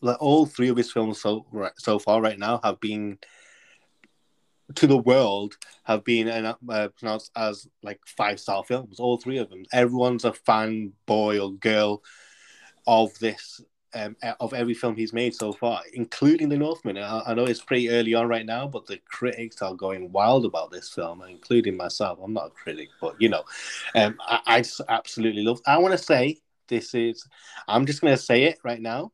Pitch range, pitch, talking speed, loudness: 105-125 Hz, 115 Hz, 200 wpm, -24 LUFS